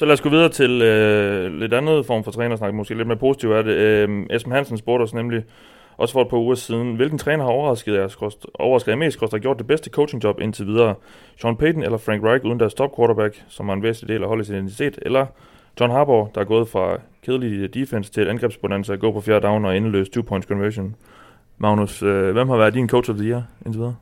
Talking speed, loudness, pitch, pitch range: 230 wpm, -20 LUFS, 115 Hz, 105-125 Hz